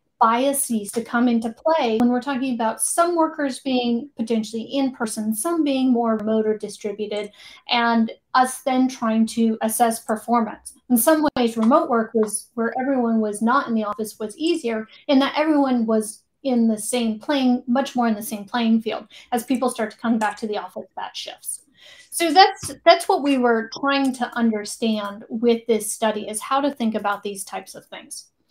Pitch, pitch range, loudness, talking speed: 235 Hz, 220-270 Hz, -21 LUFS, 190 wpm